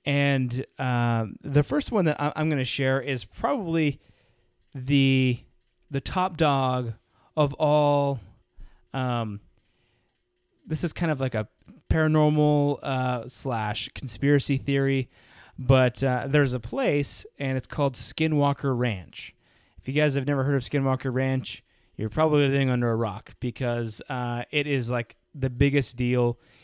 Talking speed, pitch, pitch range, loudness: 140 wpm, 130 Hz, 120-145 Hz, -25 LUFS